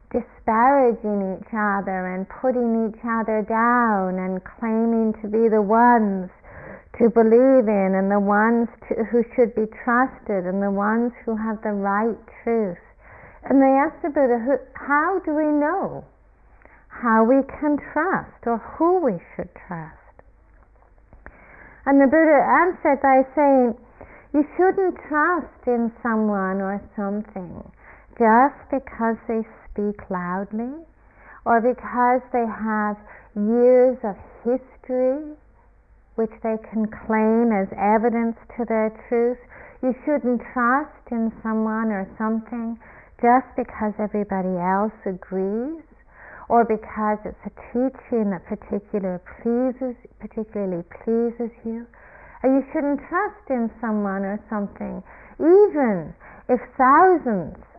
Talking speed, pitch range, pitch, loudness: 125 wpm, 210-255 Hz, 230 Hz, -21 LUFS